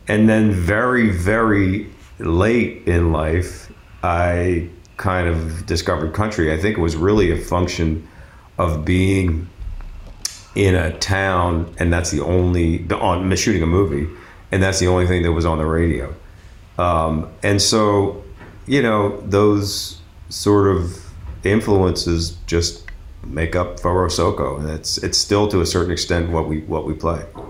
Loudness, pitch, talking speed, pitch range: -18 LUFS, 90 Hz, 150 wpm, 85-100 Hz